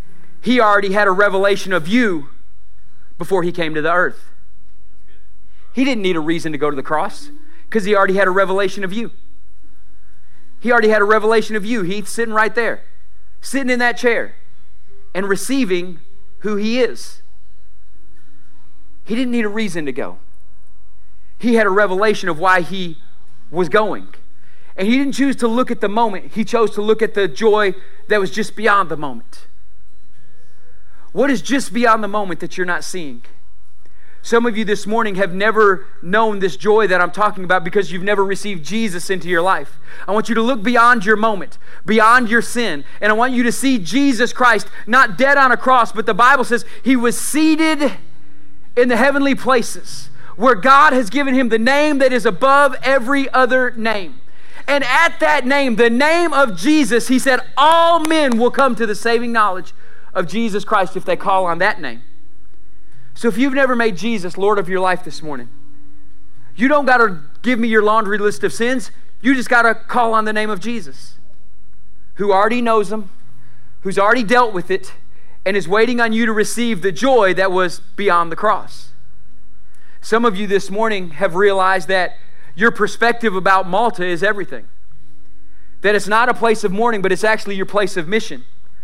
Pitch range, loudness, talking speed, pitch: 170-235 Hz, -16 LUFS, 190 wpm, 205 Hz